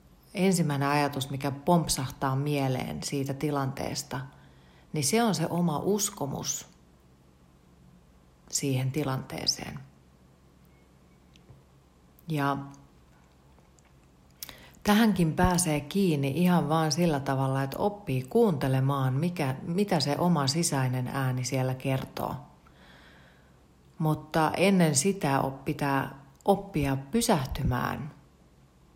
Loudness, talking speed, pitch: -28 LUFS, 85 wpm, 135 Hz